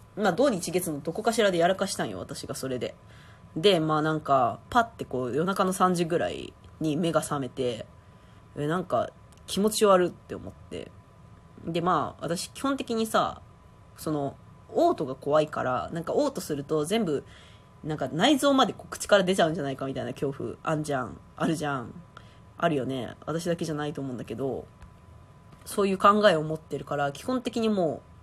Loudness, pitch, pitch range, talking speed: -27 LUFS, 160 Hz, 140-195 Hz, 350 characters per minute